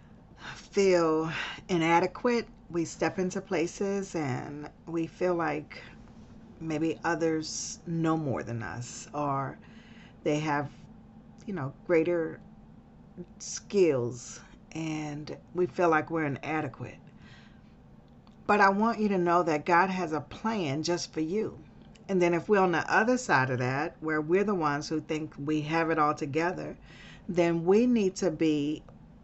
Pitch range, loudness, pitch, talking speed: 150-185 Hz, -29 LUFS, 165 Hz, 140 wpm